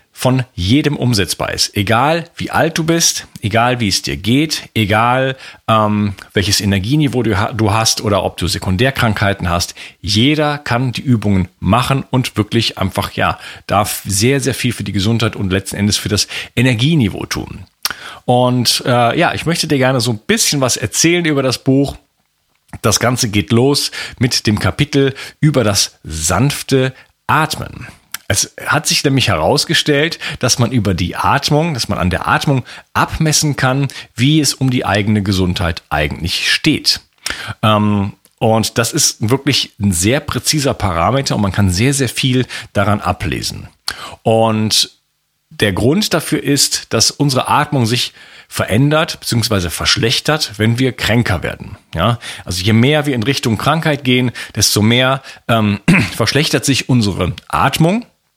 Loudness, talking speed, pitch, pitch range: -14 LUFS, 150 wpm, 120 Hz, 105-140 Hz